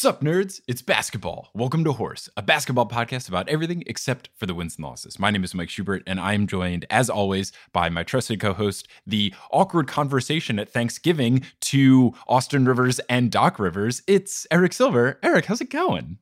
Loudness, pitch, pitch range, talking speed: -22 LUFS, 125 Hz, 100-145 Hz, 195 wpm